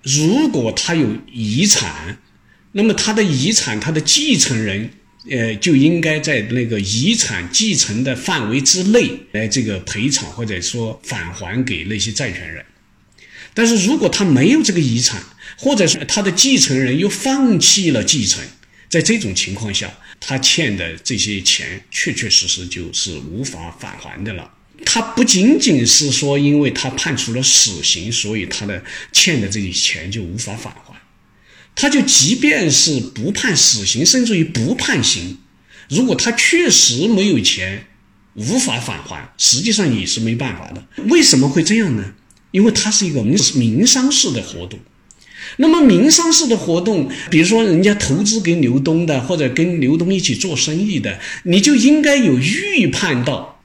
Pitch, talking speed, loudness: 140 Hz, 245 characters per minute, -14 LUFS